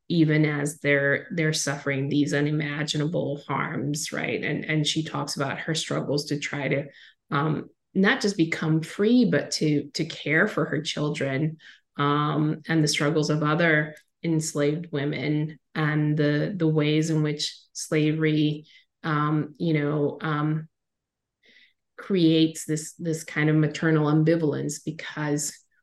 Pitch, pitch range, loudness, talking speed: 150 Hz, 145-160 Hz, -25 LUFS, 135 wpm